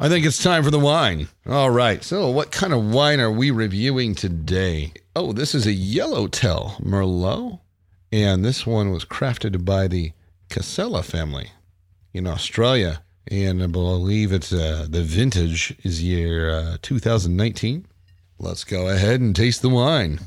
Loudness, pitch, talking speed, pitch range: -21 LUFS, 95 Hz, 155 wpm, 90-120 Hz